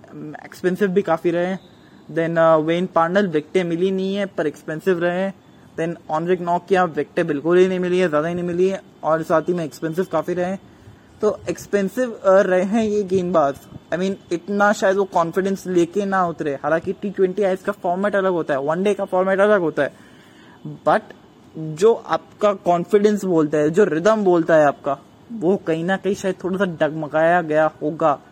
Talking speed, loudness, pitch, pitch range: 195 wpm, -20 LUFS, 180 Hz, 160-195 Hz